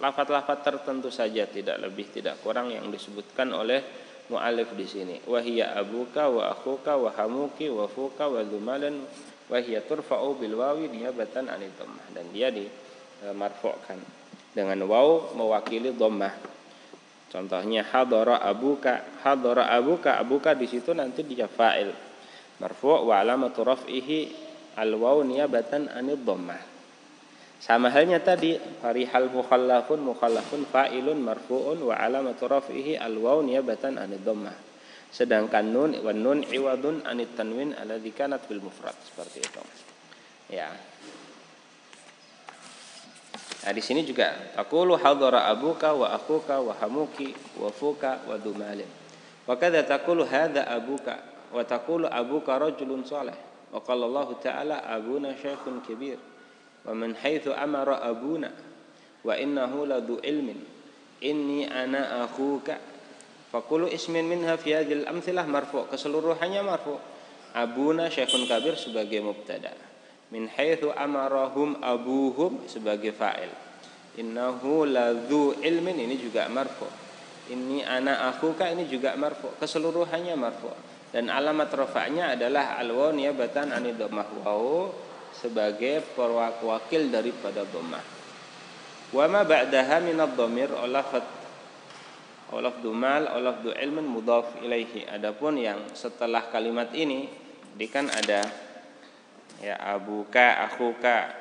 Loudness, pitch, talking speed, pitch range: -27 LUFS, 130 Hz, 115 wpm, 120-150 Hz